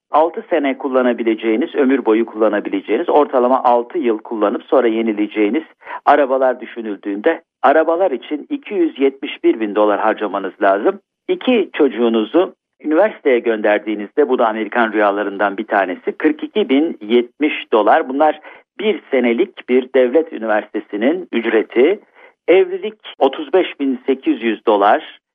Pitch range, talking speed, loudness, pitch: 110-165 Hz, 110 wpm, -16 LUFS, 130 Hz